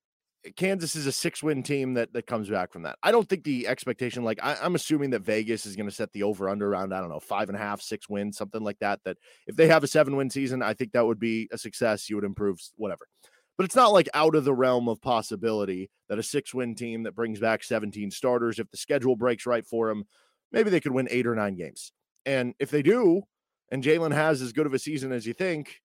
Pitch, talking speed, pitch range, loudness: 120 Hz, 260 wpm, 110-145 Hz, -27 LUFS